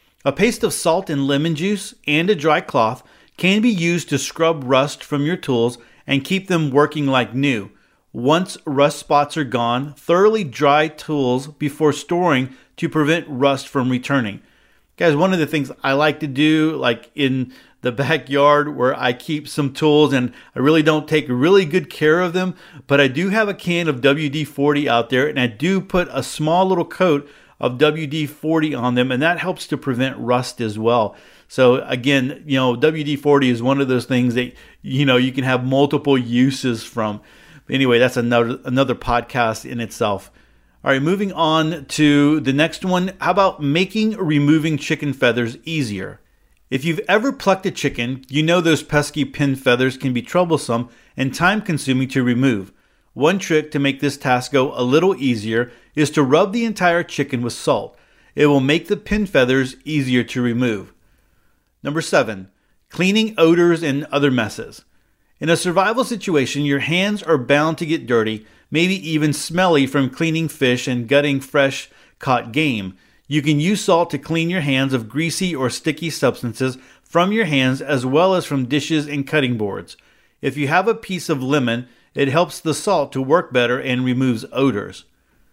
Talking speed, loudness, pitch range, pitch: 180 wpm, -18 LUFS, 125-160 Hz, 145 Hz